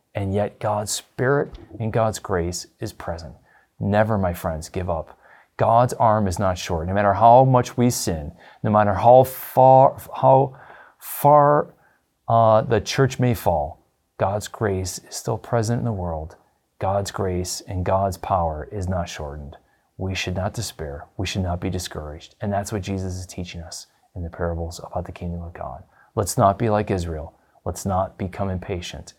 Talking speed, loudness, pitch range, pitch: 175 wpm, -21 LUFS, 85-110 Hz, 95 Hz